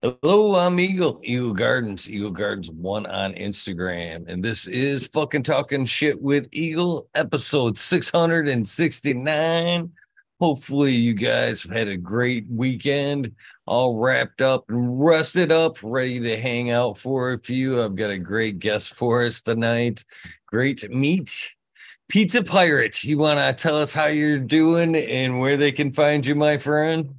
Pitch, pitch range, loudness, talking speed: 135 Hz, 115-155 Hz, -21 LUFS, 165 wpm